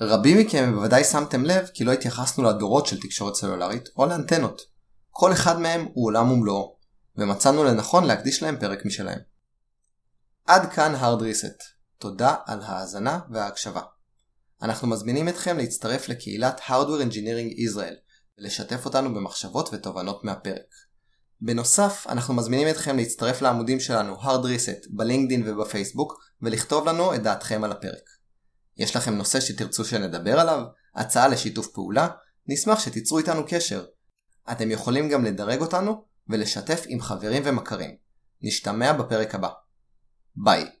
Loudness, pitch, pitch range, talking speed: -24 LUFS, 120 Hz, 105-140 Hz, 130 wpm